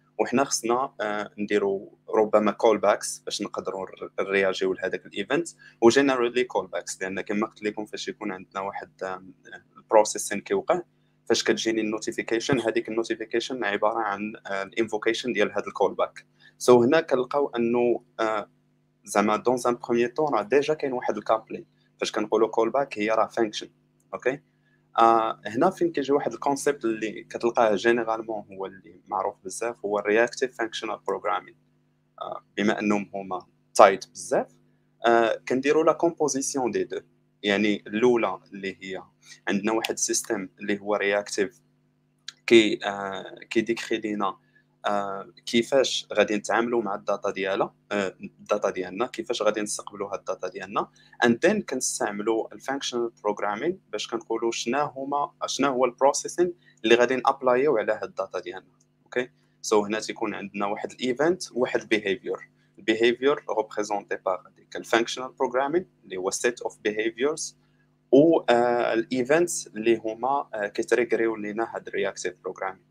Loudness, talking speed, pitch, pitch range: -26 LUFS, 145 wpm, 115 Hz, 105-125 Hz